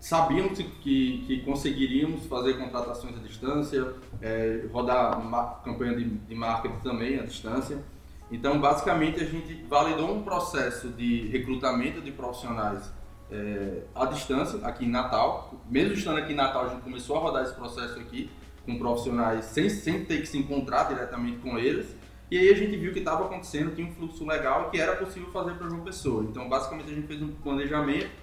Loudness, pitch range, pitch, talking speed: -29 LUFS, 120-160 Hz, 135 Hz, 185 wpm